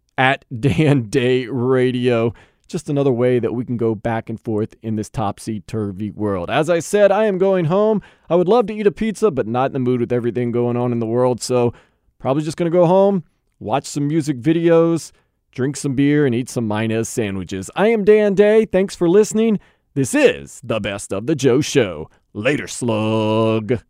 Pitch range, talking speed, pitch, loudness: 115-170 Hz, 205 wpm, 130 Hz, -18 LUFS